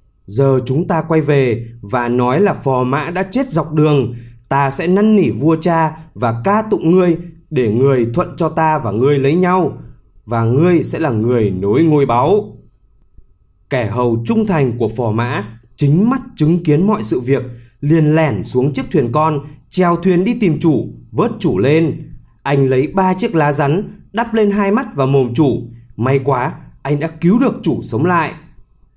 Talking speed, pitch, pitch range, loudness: 190 wpm, 145 Hz, 120-170 Hz, -15 LUFS